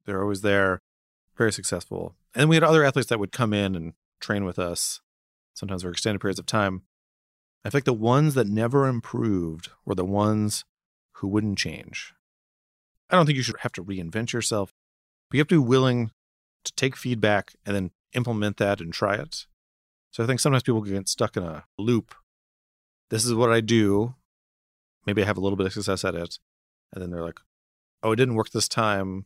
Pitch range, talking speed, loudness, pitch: 90-120 Hz, 200 wpm, -25 LUFS, 100 Hz